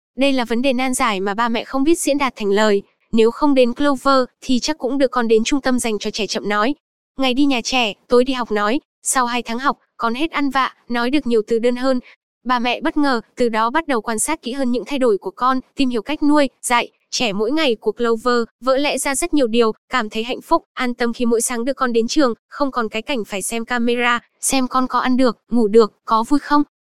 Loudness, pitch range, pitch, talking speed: -18 LUFS, 230-270 Hz, 245 Hz, 260 wpm